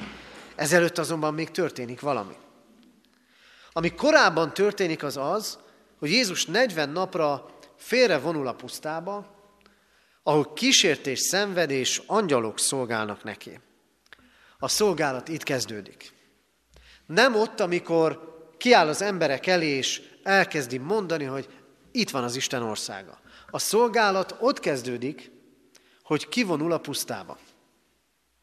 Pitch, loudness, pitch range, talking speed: 160 Hz, -25 LUFS, 135-195 Hz, 110 wpm